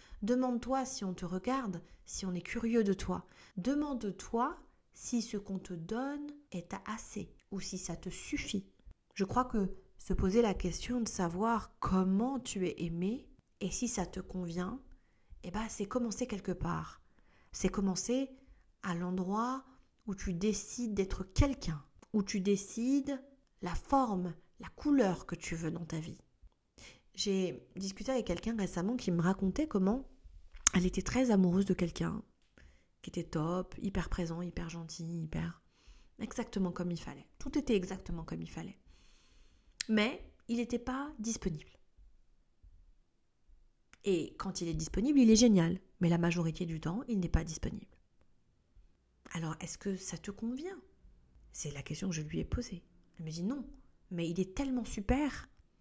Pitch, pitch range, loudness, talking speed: 190 Hz, 175-235 Hz, -36 LUFS, 160 wpm